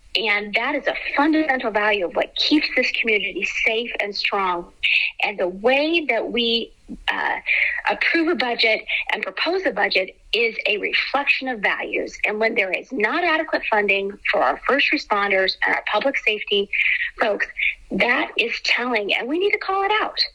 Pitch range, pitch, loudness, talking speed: 210-335 Hz, 260 Hz, -20 LUFS, 170 wpm